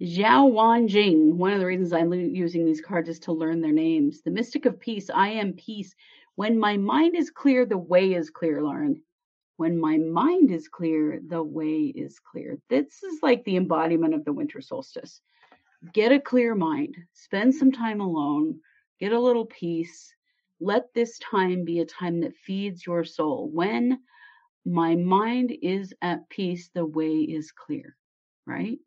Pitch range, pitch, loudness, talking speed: 170-255 Hz, 195 Hz, -24 LUFS, 175 wpm